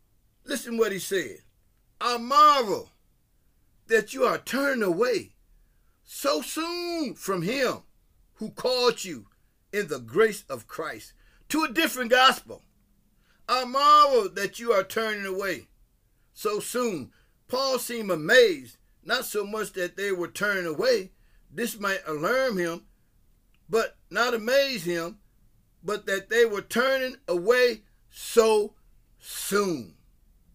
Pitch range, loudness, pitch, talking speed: 195-270 Hz, -25 LUFS, 225 Hz, 125 wpm